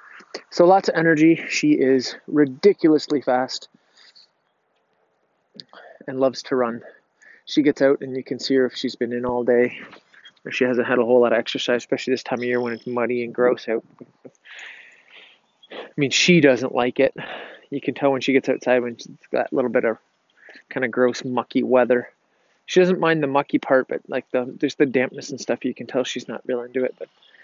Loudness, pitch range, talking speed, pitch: -21 LUFS, 125-140 Hz, 205 wpm, 130 Hz